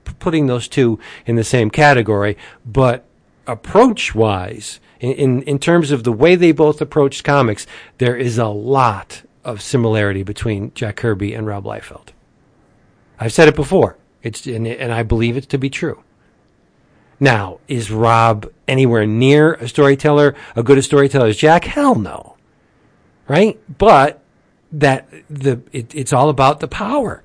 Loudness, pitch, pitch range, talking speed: -15 LUFS, 130 Hz, 115-150 Hz, 150 wpm